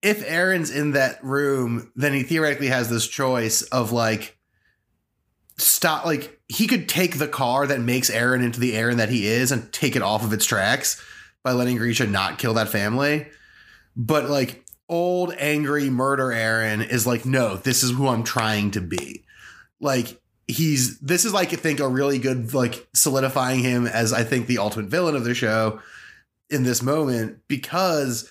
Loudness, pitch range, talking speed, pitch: -22 LUFS, 115-145 Hz, 180 wpm, 130 Hz